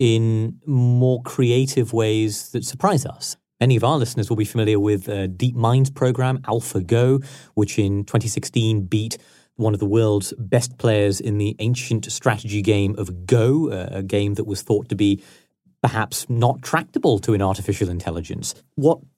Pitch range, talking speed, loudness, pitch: 105-125 Hz, 165 wpm, -21 LUFS, 110 Hz